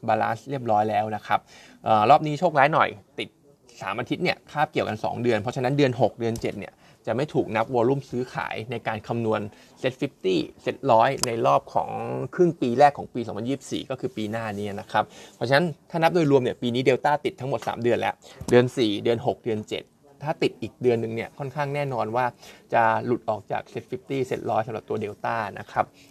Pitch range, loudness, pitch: 110-140 Hz, -25 LUFS, 120 Hz